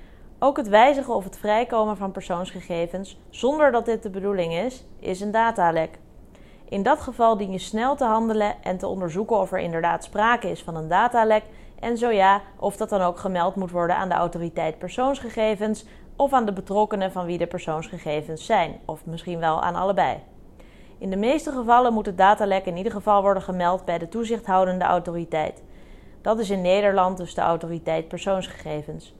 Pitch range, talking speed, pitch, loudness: 175-220 Hz, 180 wpm, 195 Hz, -23 LUFS